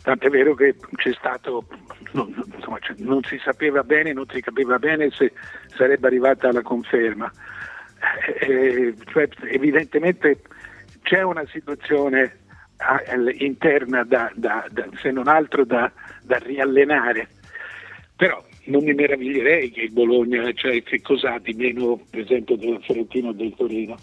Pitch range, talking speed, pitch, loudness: 120-140 Hz, 135 wpm, 130 Hz, -21 LUFS